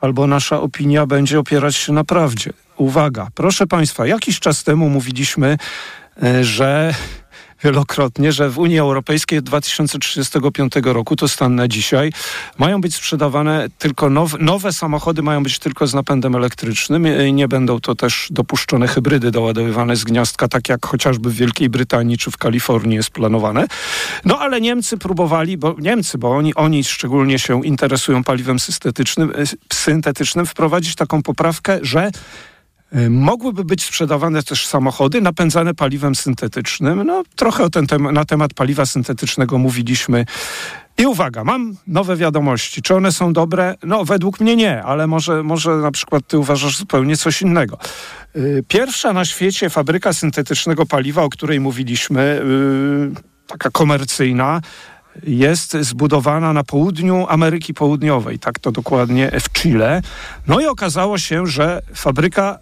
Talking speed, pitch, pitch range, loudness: 145 wpm, 150 Hz, 135-165 Hz, -16 LUFS